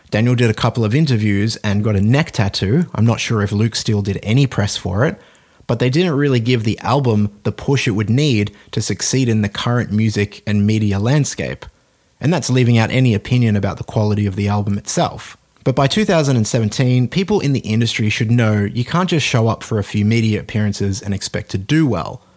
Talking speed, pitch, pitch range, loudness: 215 wpm, 110 Hz, 105-125 Hz, -17 LUFS